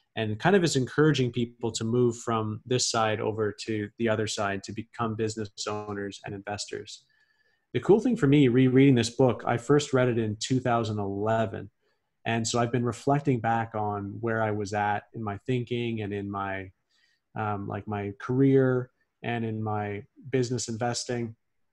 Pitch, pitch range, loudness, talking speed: 115 Hz, 105-125 Hz, -27 LUFS, 170 wpm